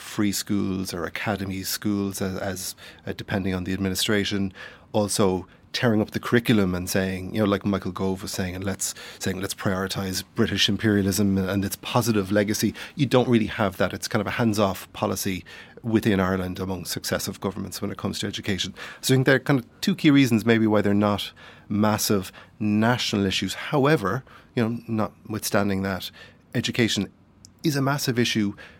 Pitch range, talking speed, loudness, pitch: 95-110 Hz, 180 wpm, -24 LUFS, 100 Hz